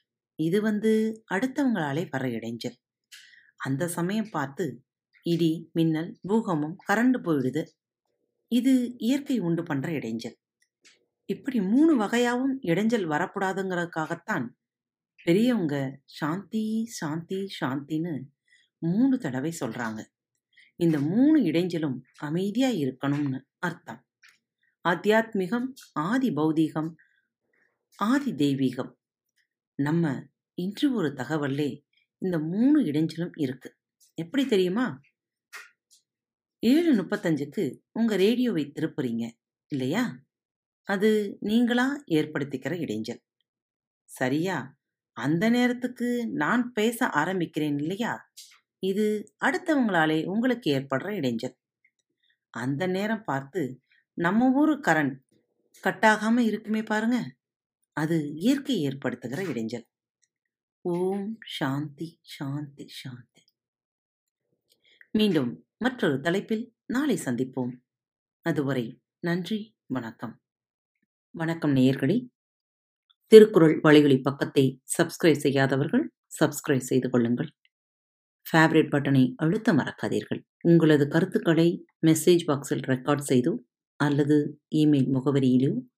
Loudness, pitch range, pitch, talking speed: -26 LUFS, 140-220 Hz, 165 Hz, 85 wpm